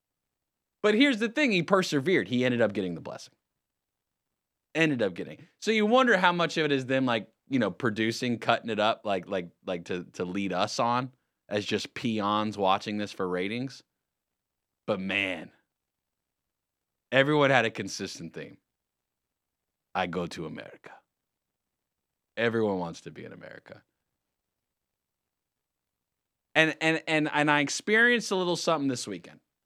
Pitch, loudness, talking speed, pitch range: 125 Hz, -27 LUFS, 150 wpm, 105-160 Hz